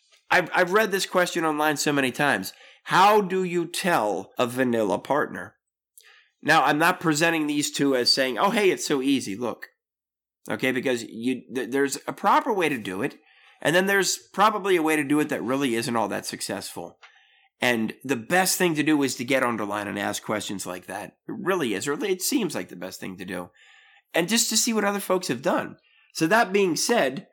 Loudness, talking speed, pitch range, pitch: -23 LUFS, 215 wpm, 130-200 Hz, 155 Hz